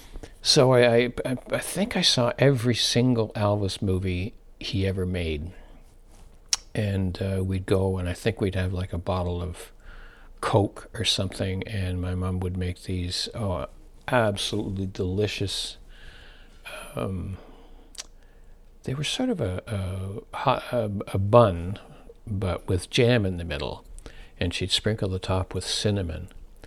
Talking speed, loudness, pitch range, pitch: 140 wpm, -26 LUFS, 90-110 Hz, 95 Hz